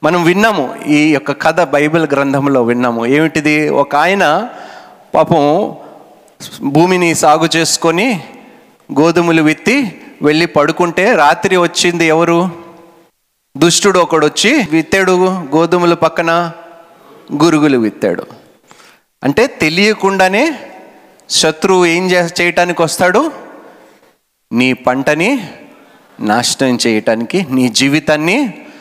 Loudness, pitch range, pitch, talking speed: -12 LUFS, 150-180 Hz, 165 Hz, 90 wpm